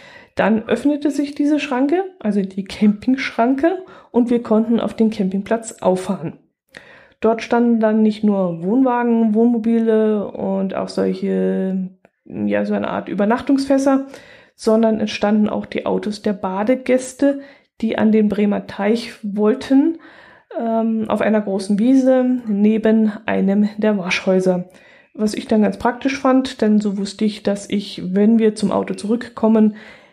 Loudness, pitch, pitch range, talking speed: -18 LUFS, 220 Hz, 205-250 Hz, 140 wpm